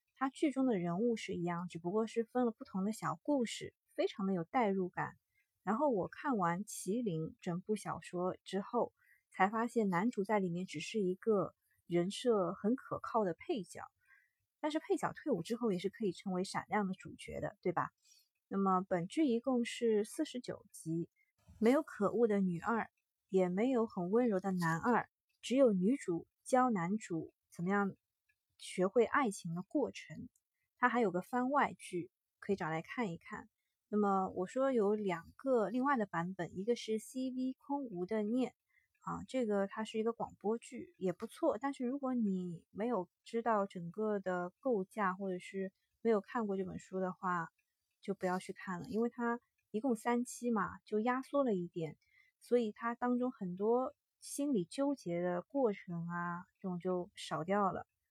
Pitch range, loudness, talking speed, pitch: 185-245 Hz, -37 LUFS, 250 characters per minute, 210 Hz